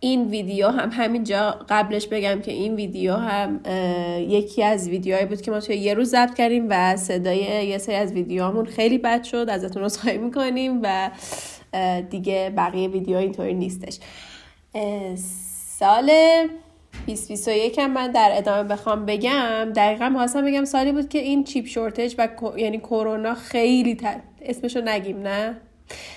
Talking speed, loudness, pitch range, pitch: 150 wpm, -22 LUFS, 195-240 Hz, 215 Hz